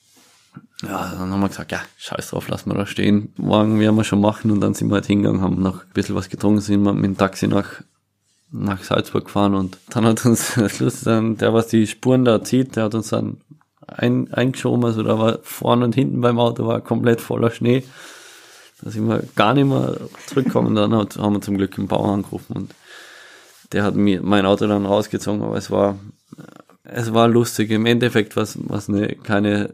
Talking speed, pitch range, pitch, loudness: 205 wpm, 100-115 Hz, 105 Hz, -19 LUFS